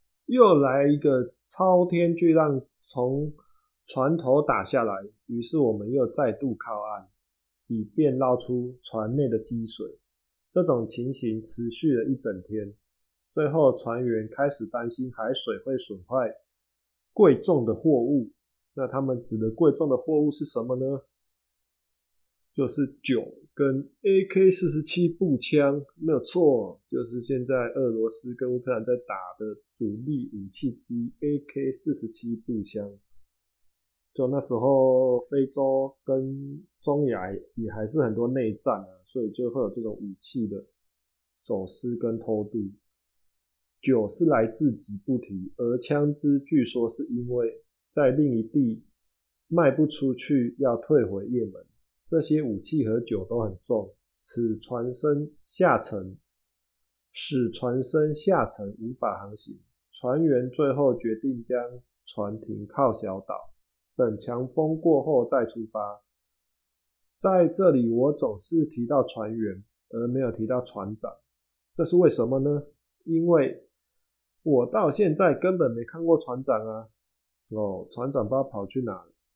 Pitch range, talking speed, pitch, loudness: 105-140 Hz, 200 characters per minute, 120 Hz, -26 LUFS